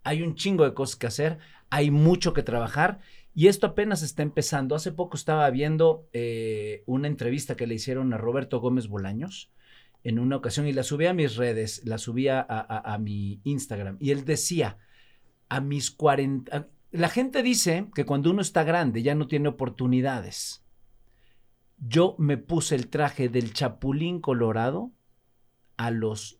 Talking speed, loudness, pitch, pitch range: 170 wpm, -26 LUFS, 135 Hz, 120-155 Hz